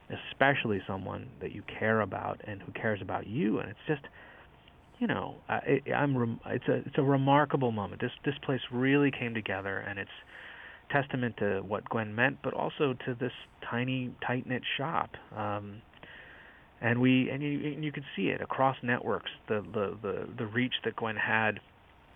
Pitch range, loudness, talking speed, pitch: 105-135 Hz, -32 LUFS, 175 wpm, 120 Hz